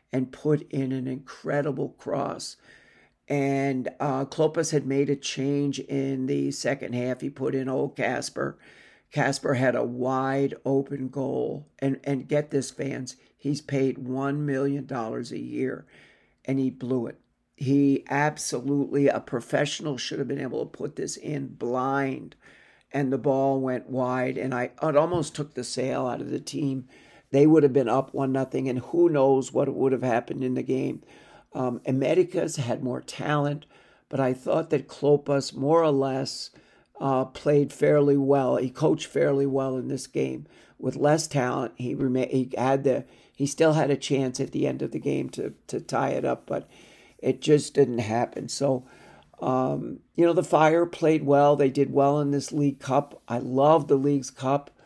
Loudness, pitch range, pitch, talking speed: -26 LUFS, 130-145 Hz, 135 Hz, 175 wpm